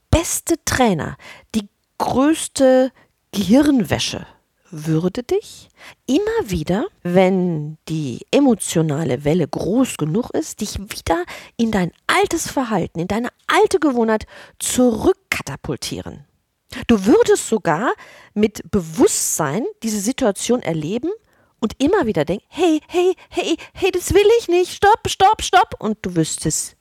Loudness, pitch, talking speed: -18 LUFS, 235 Hz, 120 wpm